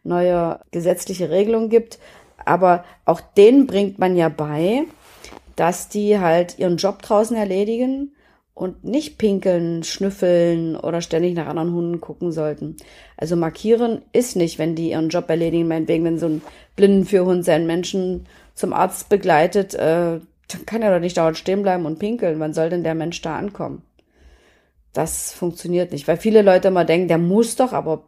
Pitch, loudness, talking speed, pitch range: 175 Hz, -19 LUFS, 165 wpm, 165-200 Hz